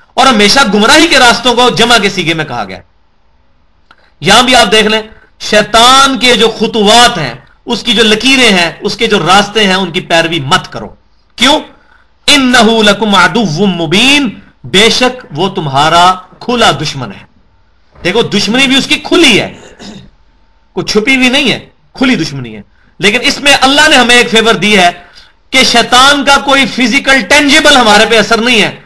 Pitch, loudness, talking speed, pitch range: 220 Hz, -6 LUFS, 175 wpm, 180-250 Hz